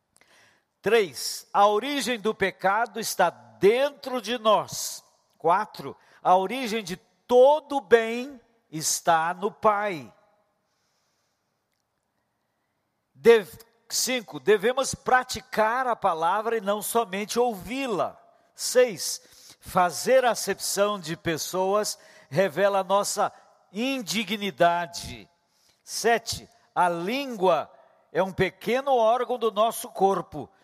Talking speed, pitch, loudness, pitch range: 95 wpm, 215 Hz, -25 LUFS, 190-245 Hz